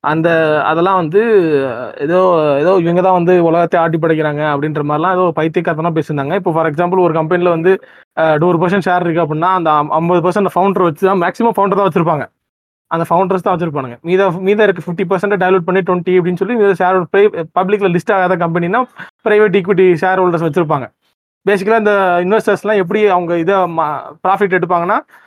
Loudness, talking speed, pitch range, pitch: -13 LUFS, 165 wpm, 165-195 Hz, 180 Hz